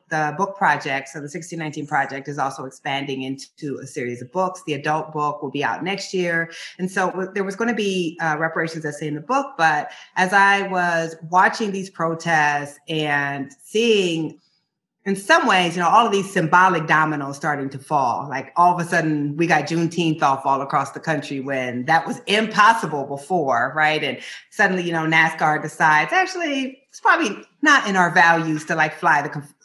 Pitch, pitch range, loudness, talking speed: 160 Hz, 145-185 Hz, -20 LUFS, 195 wpm